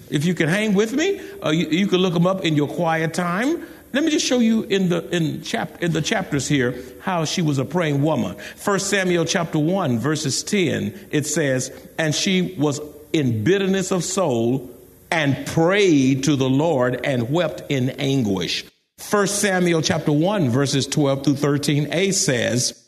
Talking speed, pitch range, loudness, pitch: 185 wpm, 140-190 Hz, -20 LUFS, 160 Hz